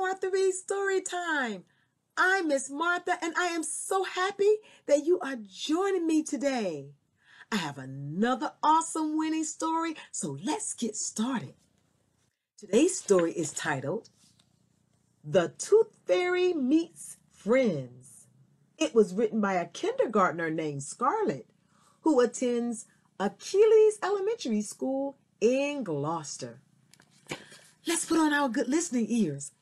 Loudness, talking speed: -28 LUFS, 115 wpm